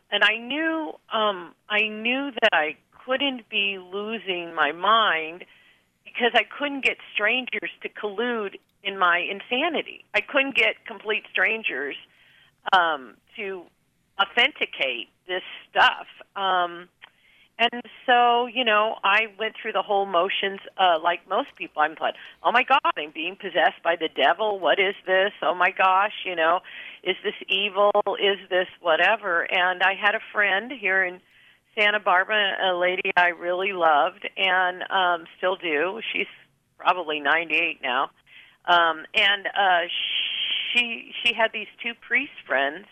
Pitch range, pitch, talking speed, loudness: 180-220 Hz, 195 Hz, 150 wpm, -23 LUFS